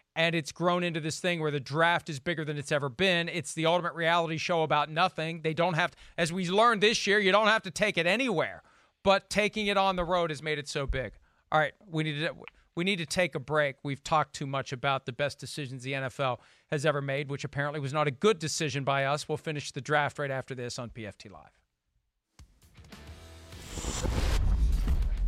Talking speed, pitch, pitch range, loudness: 220 wpm, 155 Hz, 135-170 Hz, -29 LUFS